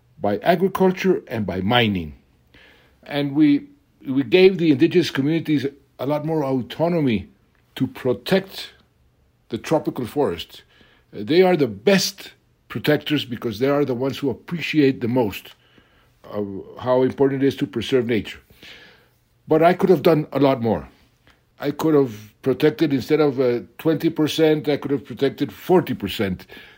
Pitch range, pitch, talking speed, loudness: 120-160 Hz, 140 Hz, 150 wpm, -20 LUFS